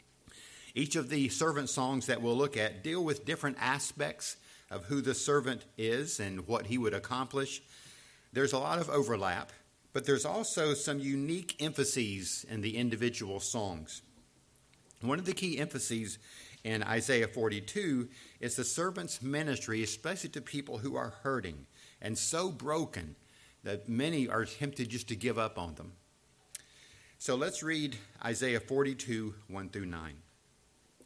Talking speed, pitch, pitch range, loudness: 150 wpm, 125 Hz, 110-145 Hz, -35 LUFS